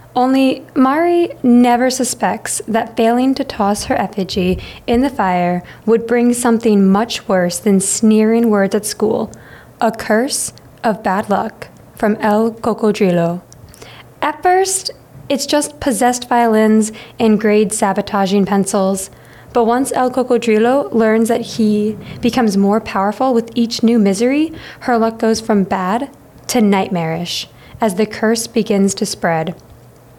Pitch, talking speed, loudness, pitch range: 225 Hz, 135 wpm, -15 LUFS, 205-245 Hz